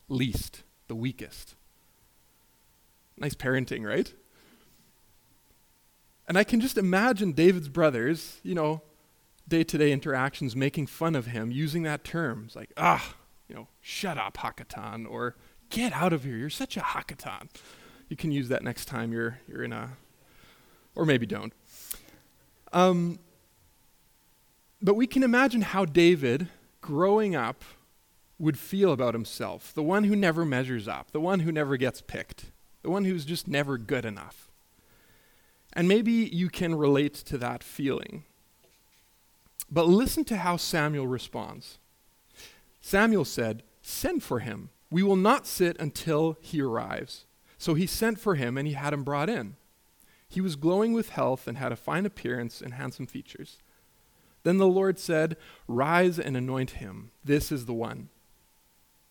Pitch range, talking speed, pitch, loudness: 130-185 Hz, 150 wpm, 155 Hz, -28 LUFS